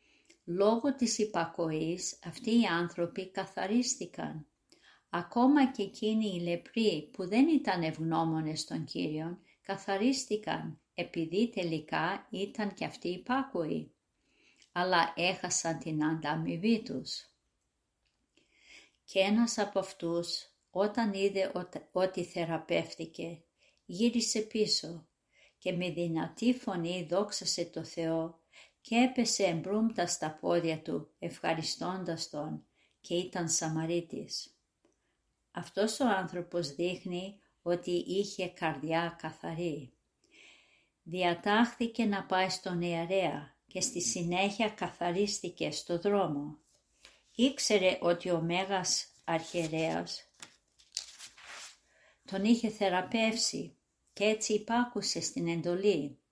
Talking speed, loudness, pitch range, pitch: 95 wpm, -33 LUFS, 170-210 Hz, 180 Hz